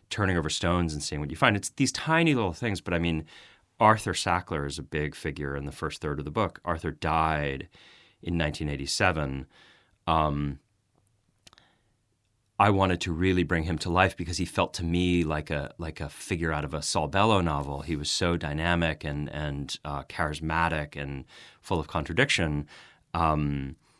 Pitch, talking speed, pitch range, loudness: 80 Hz, 180 wpm, 75-90 Hz, -28 LUFS